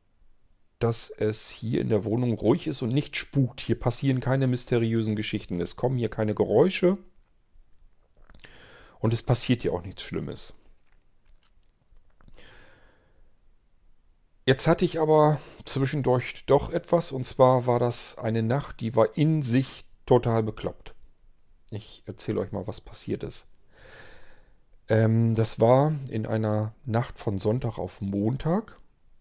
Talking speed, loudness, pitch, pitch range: 130 wpm, -26 LUFS, 120 Hz, 110-135 Hz